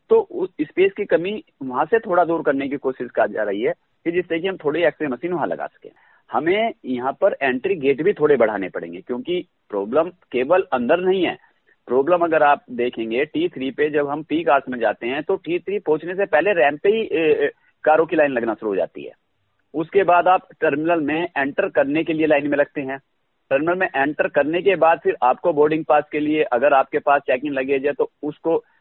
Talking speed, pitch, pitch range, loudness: 220 wpm, 160 Hz, 145-200 Hz, -20 LUFS